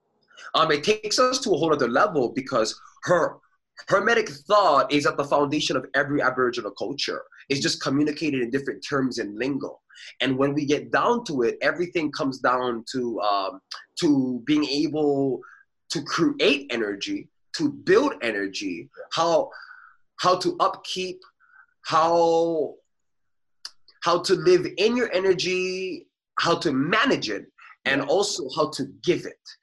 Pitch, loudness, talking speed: 180 Hz, -24 LUFS, 145 wpm